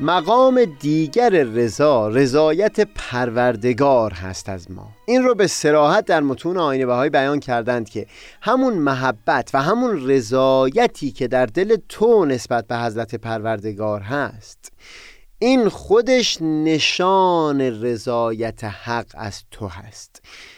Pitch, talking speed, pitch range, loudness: 130 Hz, 120 wpm, 115-170 Hz, -18 LUFS